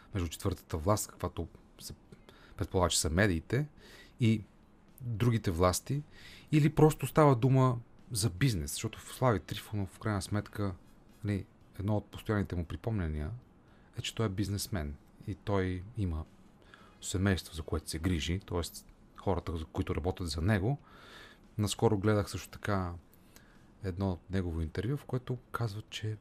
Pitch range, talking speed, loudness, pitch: 90-110 Hz, 140 wpm, -33 LUFS, 100 Hz